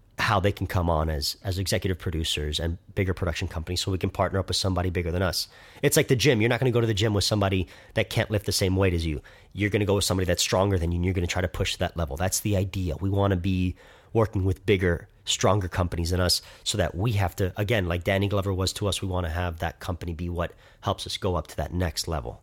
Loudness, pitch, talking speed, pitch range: -26 LUFS, 95 Hz, 275 wpm, 90-100 Hz